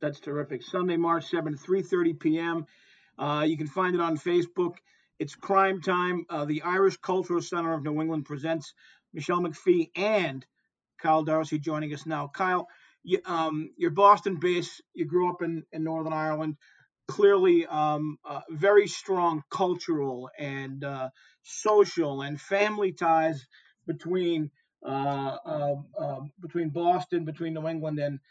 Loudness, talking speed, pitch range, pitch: -28 LUFS, 150 wpm, 150-180 Hz, 165 Hz